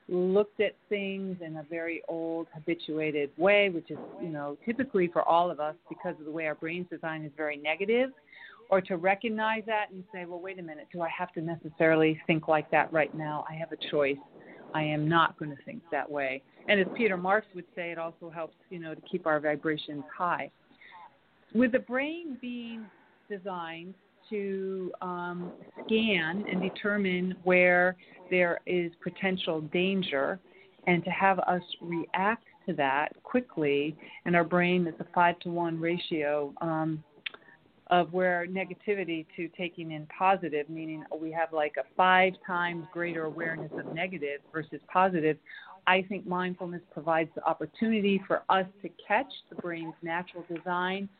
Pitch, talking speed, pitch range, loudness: 175 Hz, 170 wpm, 160-190 Hz, -30 LUFS